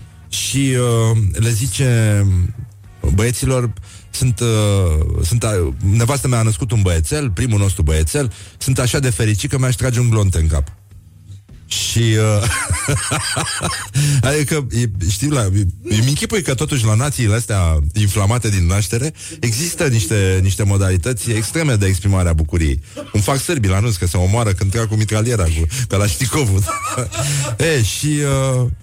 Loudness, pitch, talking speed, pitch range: -17 LUFS, 110 Hz, 145 wpm, 95-125 Hz